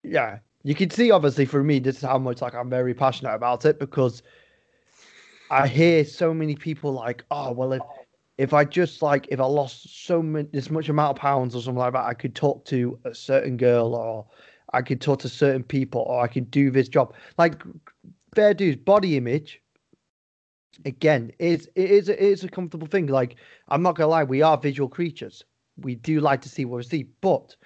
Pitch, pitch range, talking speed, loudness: 140 Hz, 130-160 Hz, 210 wpm, -23 LUFS